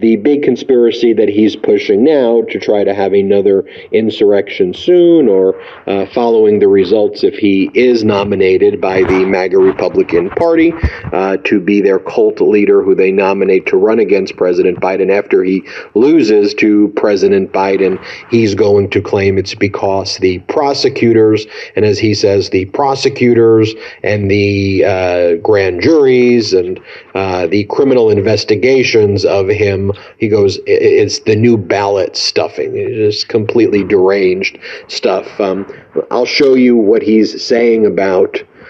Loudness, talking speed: -11 LUFS, 145 wpm